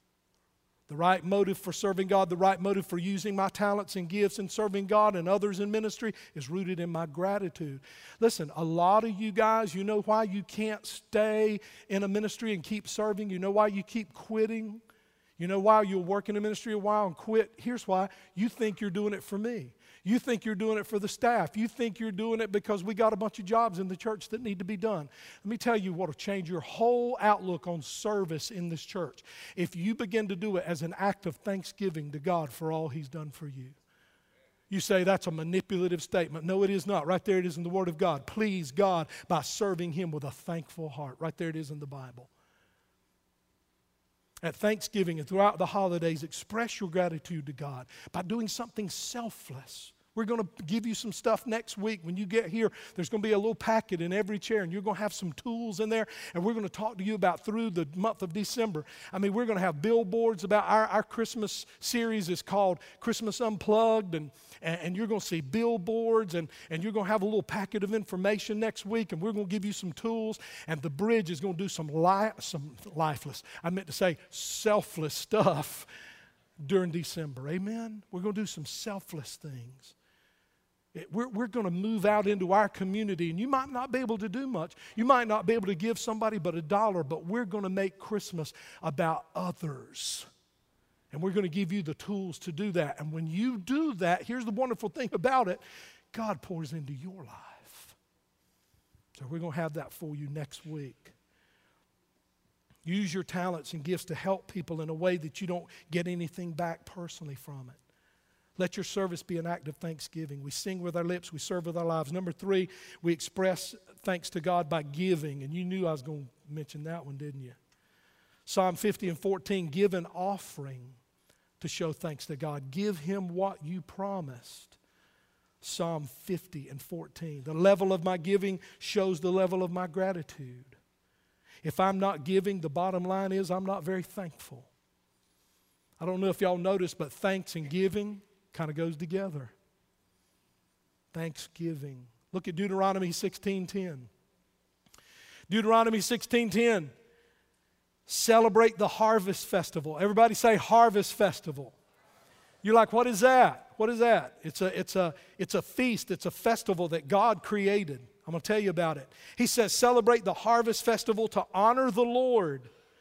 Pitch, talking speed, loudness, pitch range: 190 Hz, 200 wpm, -31 LUFS, 165-215 Hz